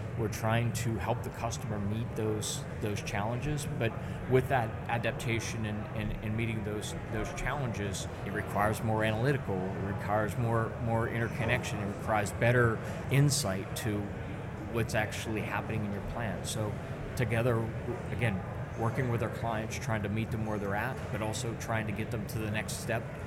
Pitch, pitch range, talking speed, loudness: 115 Hz, 105-120 Hz, 170 wpm, -33 LUFS